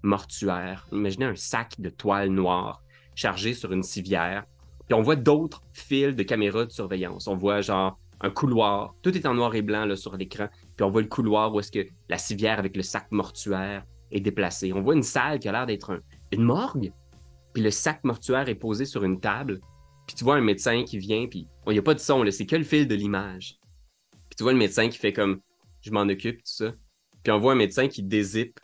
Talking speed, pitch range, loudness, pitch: 235 wpm, 95-115 Hz, -26 LUFS, 100 Hz